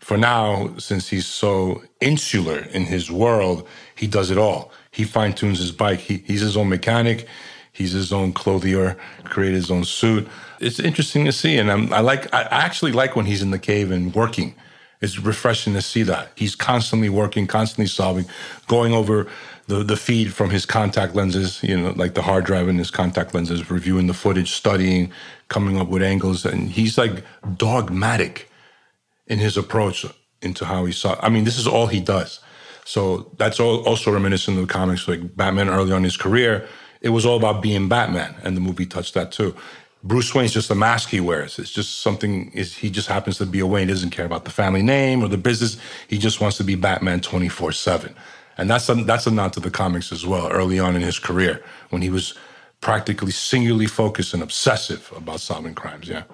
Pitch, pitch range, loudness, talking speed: 100 Hz, 95-110 Hz, -20 LUFS, 205 wpm